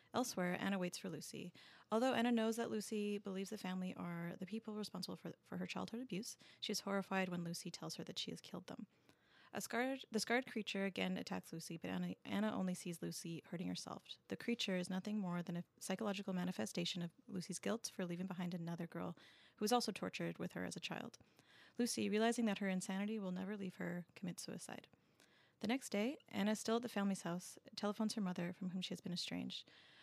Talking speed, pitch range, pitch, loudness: 210 wpm, 175-215 Hz, 195 Hz, -43 LUFS